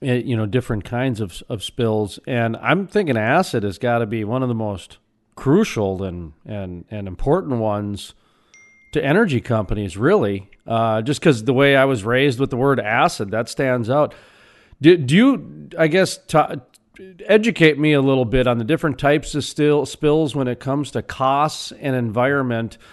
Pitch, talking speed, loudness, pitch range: 125 Hz, 180 wpm, -19 LUFS, 110-145 Hz